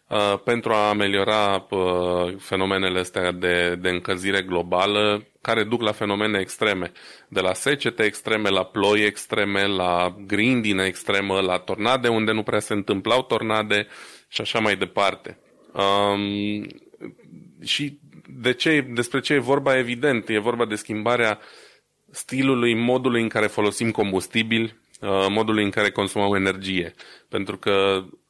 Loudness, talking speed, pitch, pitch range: -22 LUFS, 130 wpm, 105 Hz, 95-115 Hz